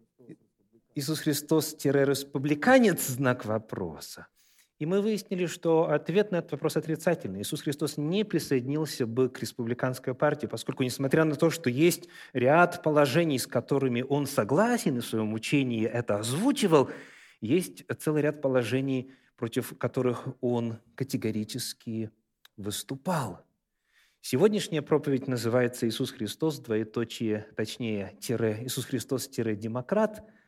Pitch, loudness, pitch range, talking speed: 135 Hz, -28 LUFS, 120-155 Hz, 115 wpm